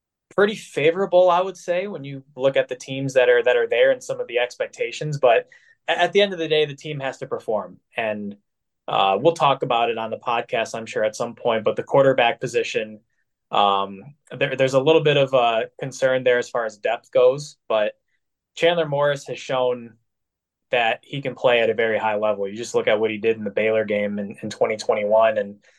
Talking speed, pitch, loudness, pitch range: 225 wpm, 135 Hz, -21 LUFS, 110-170 Hz